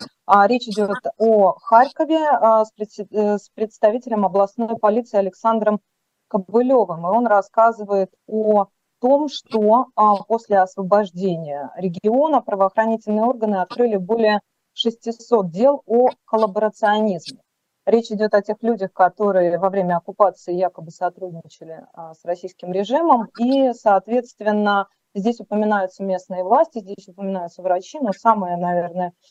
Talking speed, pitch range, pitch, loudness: 110 wpm, 190-225 Hz, 210 Hz, -19 LUFS